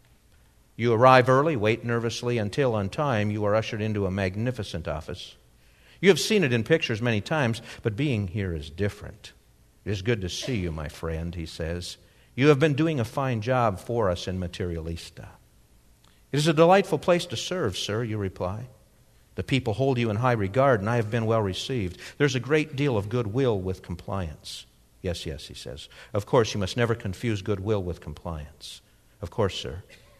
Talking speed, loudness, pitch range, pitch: 195 wpm, -26 LUFS, 90-125 Hz, 110 Hz